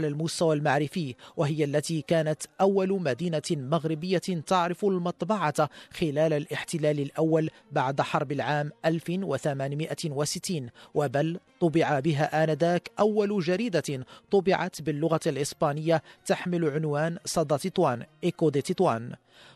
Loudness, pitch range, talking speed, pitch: -27 LUFS, 150-175 Hz, 100 wpm, 160 Hz